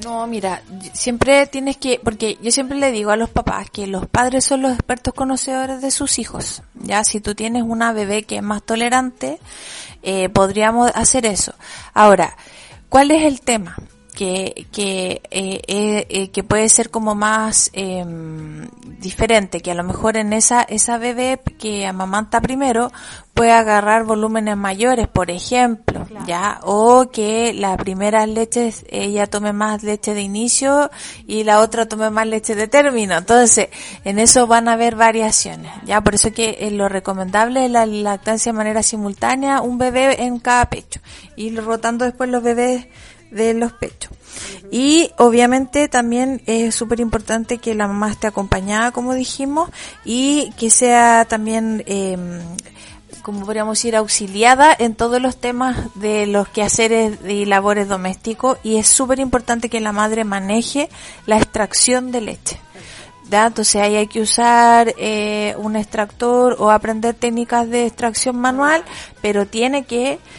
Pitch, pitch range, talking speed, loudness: 225 Hz, 210-245 Hz, 160 wpm, -16 LUFS